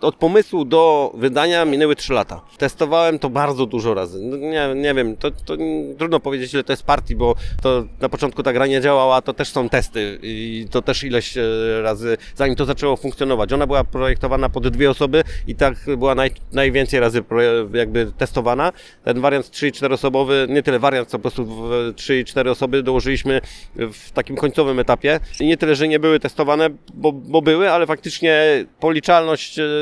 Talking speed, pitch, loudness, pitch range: 180 wpm, 135 Hz, -18 LUFS, 125-150 Hz